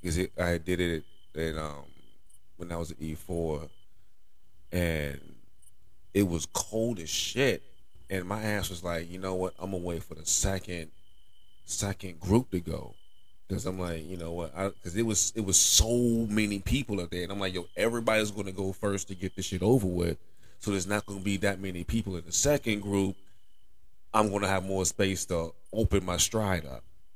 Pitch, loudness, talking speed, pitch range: 95 Hz, -30 LUFS, 200 wpm, 85-100 Hz